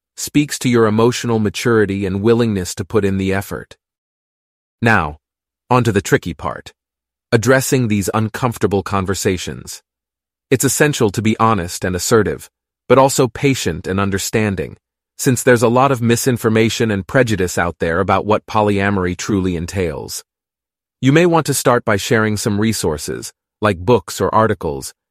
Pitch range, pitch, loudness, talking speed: 95-120 Hz, 105 Hz, -16 LUFS, 150 wpm